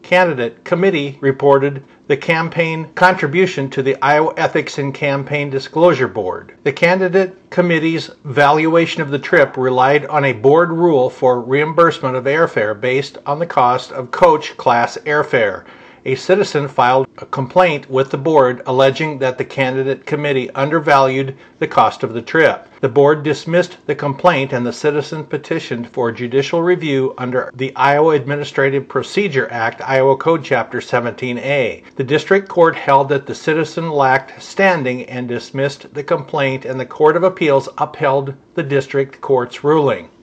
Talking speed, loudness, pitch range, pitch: 150 wpm, -15 LUFS, 135-165 Hz, 145 Hz